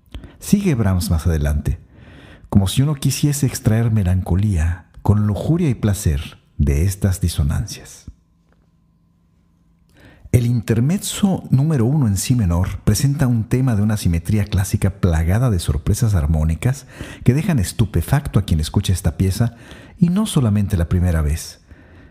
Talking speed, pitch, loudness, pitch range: 135 wpm, 100 Hz, -19 LUFS, 85-120 Hz